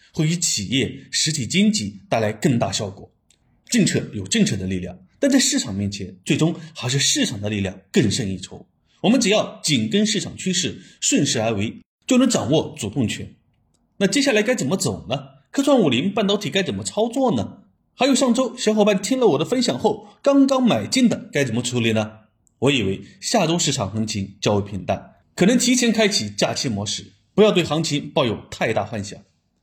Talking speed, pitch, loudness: 290 characters per minute, 170 Hz, -20 LUFS